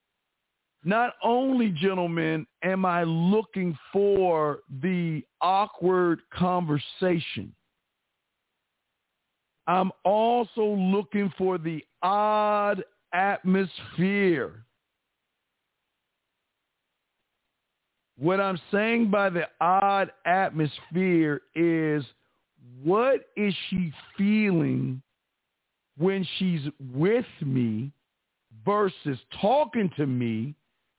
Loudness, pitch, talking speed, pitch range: -26 LUFS, 180 Hz, 70 wpm, 150-200 Hz